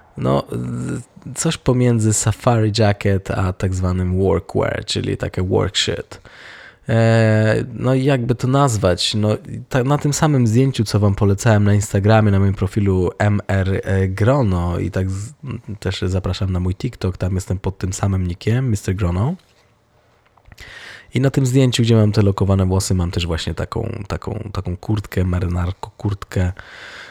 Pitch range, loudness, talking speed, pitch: 95-120 Hz, -18 LUFS, 140 wpm, 105 Hz